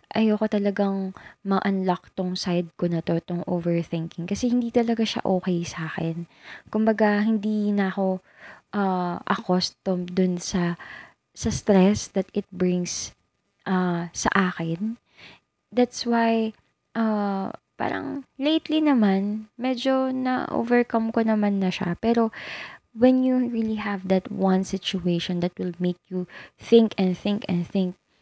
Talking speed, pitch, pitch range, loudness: 130 wpm, 195 Hz, 180-225 Hz, -24 LUFS